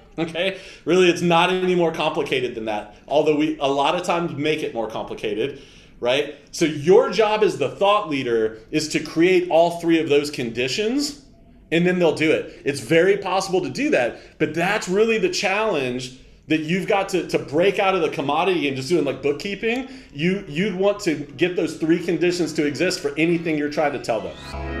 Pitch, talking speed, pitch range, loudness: 170 Hz, 200 wpm, 150-195 Hz, -21 LUFS